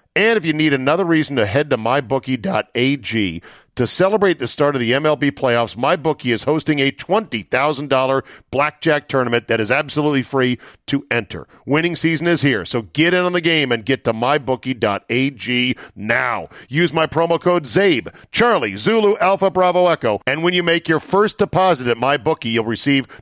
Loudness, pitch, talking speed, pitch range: -17 LUFS, 145 Hz, 175 wpm, 125-165 Hz